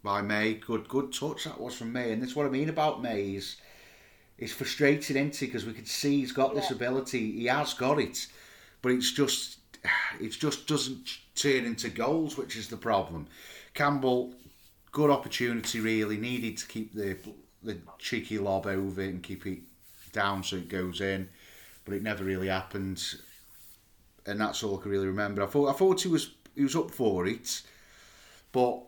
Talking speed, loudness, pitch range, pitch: 185 wpm, -31 LUFS, 100-135 Hz, 110 Hz